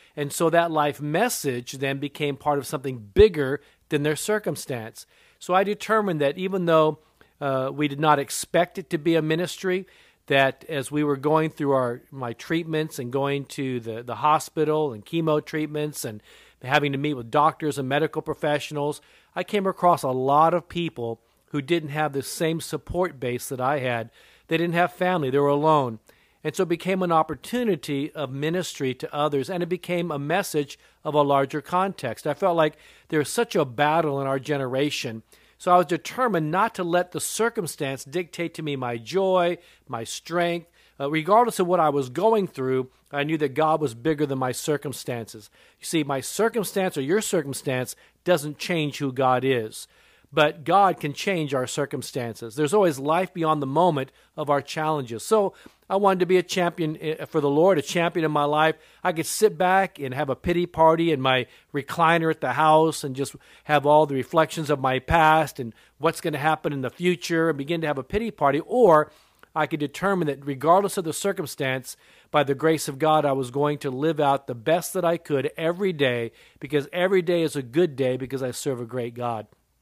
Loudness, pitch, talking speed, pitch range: -24 LUFS, 150 Hz, 200 wpm, 140-170 Hz